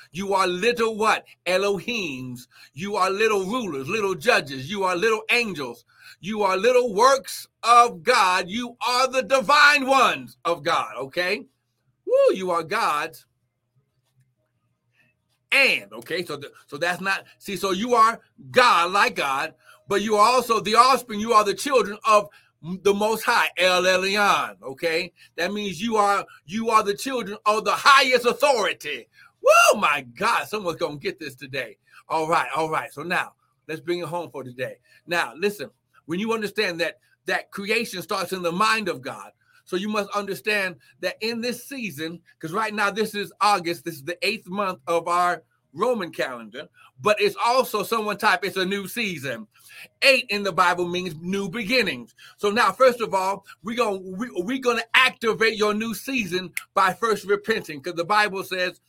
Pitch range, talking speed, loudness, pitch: 175-225 Hz, 175 wpm, -22 LUFS, 200 Hz